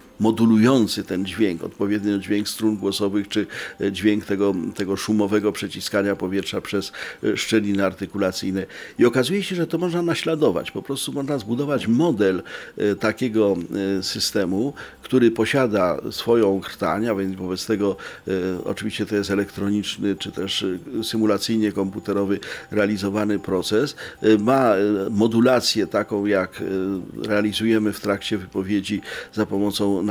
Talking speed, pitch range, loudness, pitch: 120 wpm, 100-110 Hz, -22 LUFS, 105 Hz